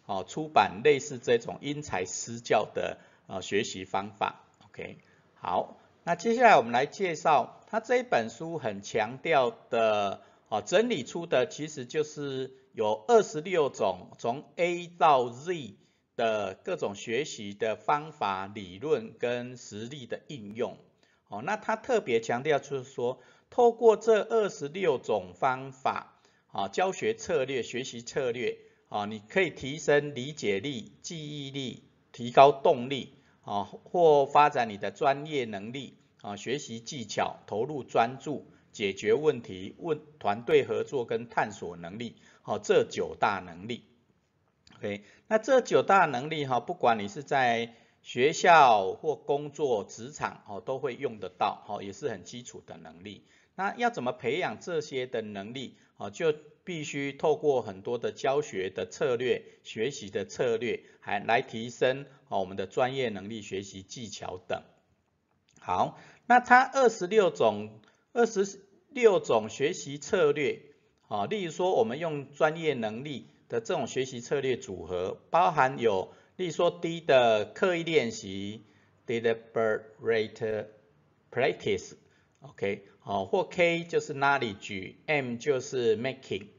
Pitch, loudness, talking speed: 150 Hz, -29 LUFS, 235 characters per minute